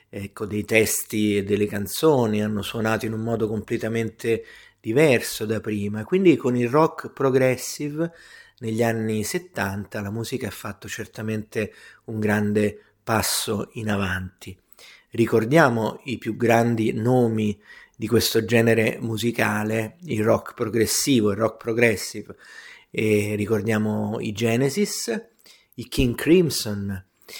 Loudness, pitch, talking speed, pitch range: -23 LUFS, 110 Hz, 120 wpm, 105-120 Hz